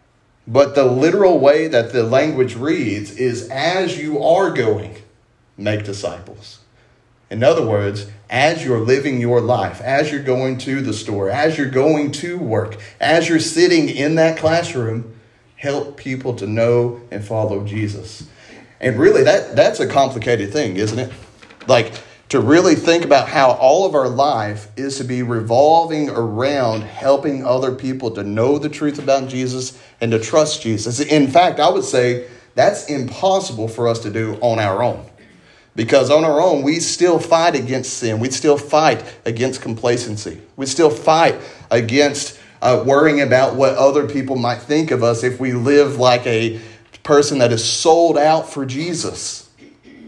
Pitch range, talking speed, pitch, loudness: 115-145 Hz, 165 wpm, 130 Hz, -16 LUFS